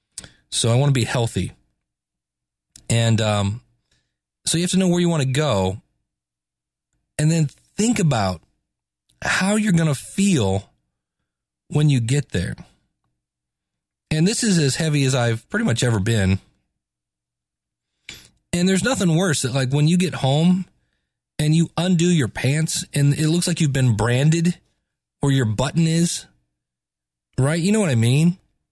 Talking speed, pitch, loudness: 155 wpm, 135 Hz, -20 LUFS